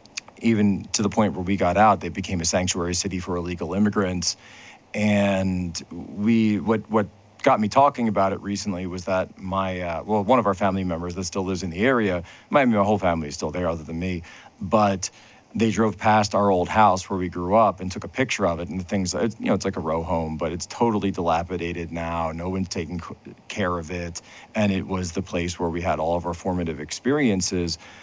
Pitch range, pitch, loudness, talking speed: 90-105 Hz, 95 Hz, -23 LUFS, 220 wpm